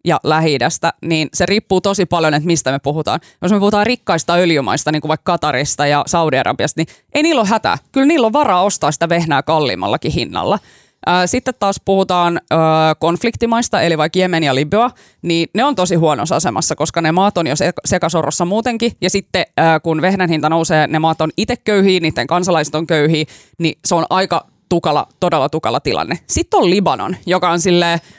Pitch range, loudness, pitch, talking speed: 155-195 Hz, -15 LUFS, 170 Hz, 185 wpm